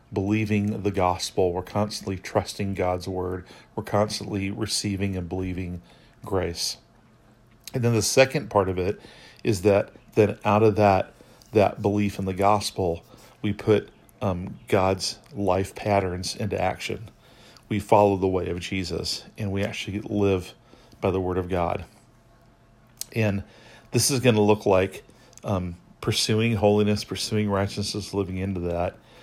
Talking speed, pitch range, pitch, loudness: 145 wpm, 95-110 Hz, 105 Hz, -25 LUFS